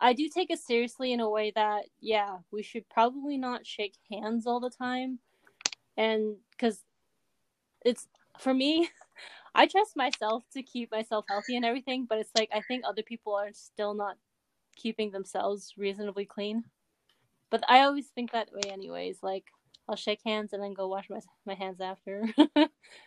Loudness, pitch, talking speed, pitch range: -31 LUFS, 220 Hz, 170 wpm, 205-250 Hz